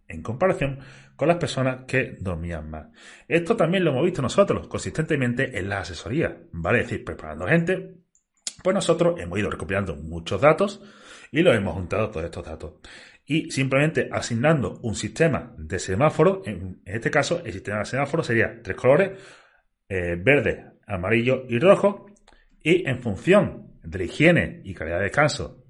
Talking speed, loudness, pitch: 160 wpm, -23 LUFS, 125 Hz